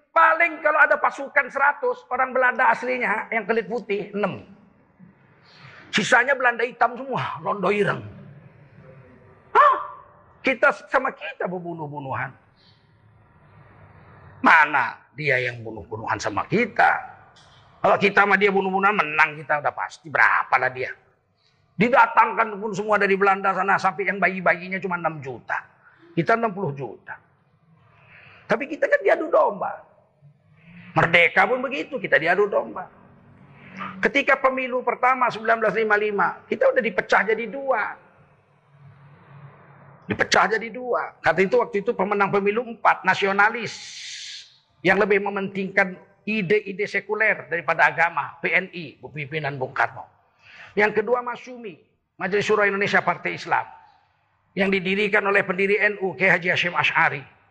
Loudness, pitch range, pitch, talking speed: -21 LUFS, 165-230 Hz, 200 Hz, 120 wpm